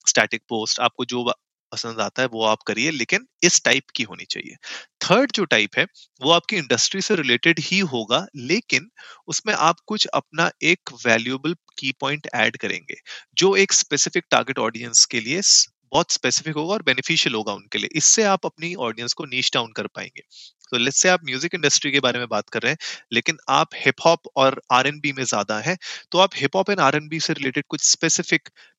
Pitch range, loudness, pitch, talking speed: 125-170 Hz, -20 LUFS, 145 Hz, 195 wpm